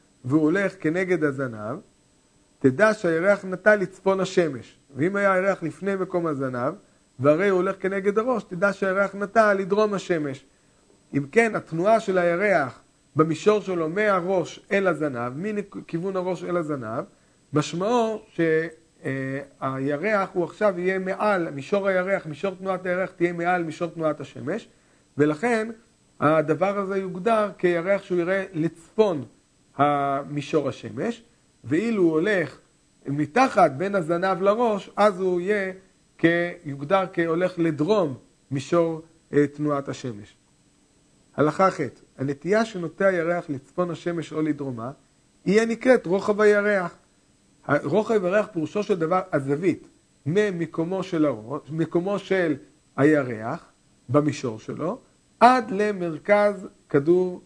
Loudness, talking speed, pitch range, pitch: -24 LUFS, 115 wpm, 150-200 Hz, 175 Hz